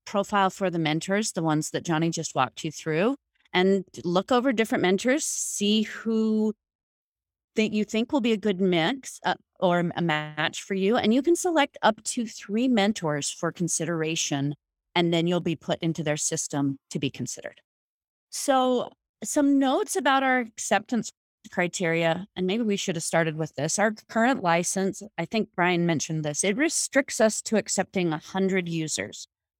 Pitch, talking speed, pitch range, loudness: 190 Hz, 170 wpm, 165-225 Hz, -25 LUFS